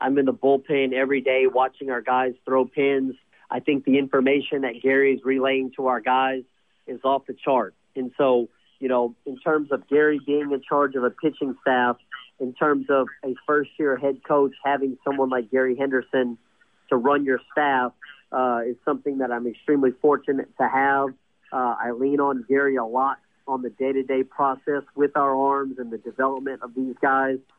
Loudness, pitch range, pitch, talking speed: -23 LUFS, 130-140 Hz, 135 Hz, 195 wpm